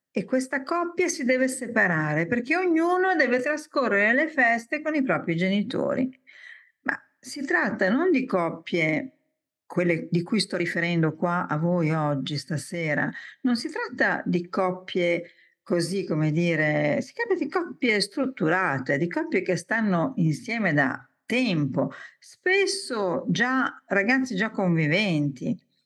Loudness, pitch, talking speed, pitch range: -25 LUFS, 210 Hz, 130 wpm, 170-280 Hz